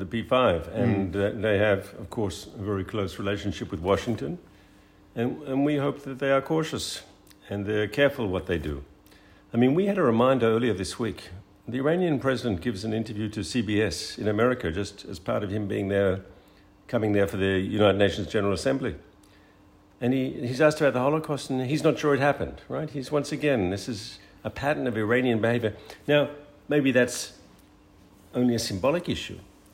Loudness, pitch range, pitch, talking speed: -26 LUFS, 100-130 Hz, 110 Hz, 190 wpm